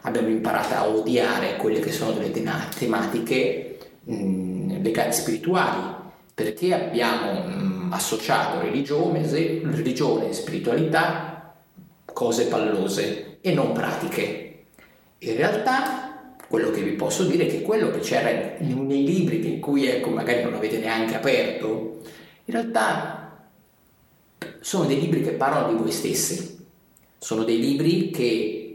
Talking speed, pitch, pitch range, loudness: 130 wpm, 155 Hz, 110-180 Hz, -24 LUFS